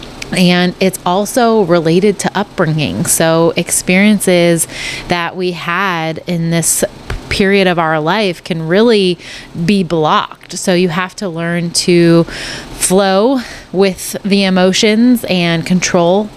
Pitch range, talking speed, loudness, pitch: 170-195 Hz, 120 wpm, -12 LUFS, 180 Hz